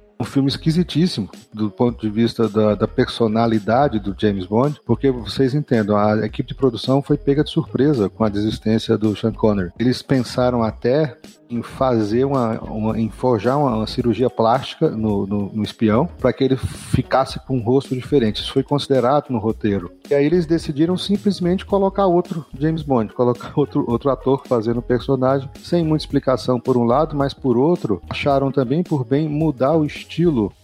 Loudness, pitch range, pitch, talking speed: -19 LUFS, 110-145 Hz, 125 Hz, 180 wpm